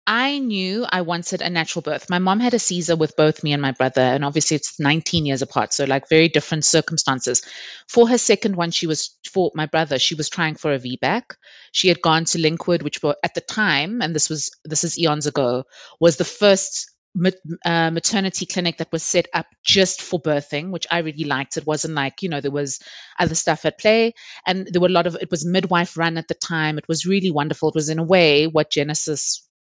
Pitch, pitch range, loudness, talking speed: 165 Hz, 150-180 Hz, -20 LUFS, 230 wpm